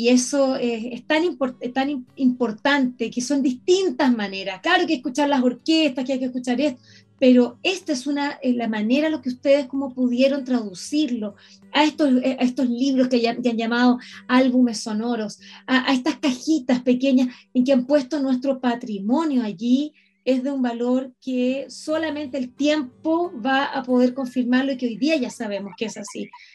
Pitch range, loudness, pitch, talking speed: 245-285 Hz, -22 LUFS, 260 Hz, 190 wpm